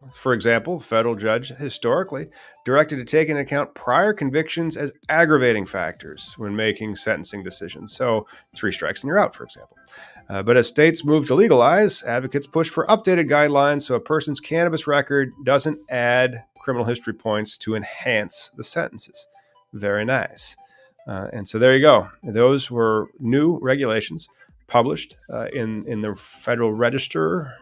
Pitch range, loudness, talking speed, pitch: 115-155 Hz, -20 LUFS, 160 wpm, 130 Hz